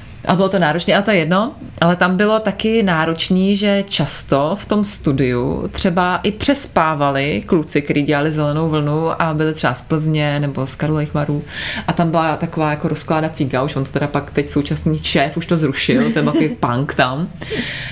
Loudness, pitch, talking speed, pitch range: -17 LUFS, 160 Hz, 185 wpm, 145-185 Hz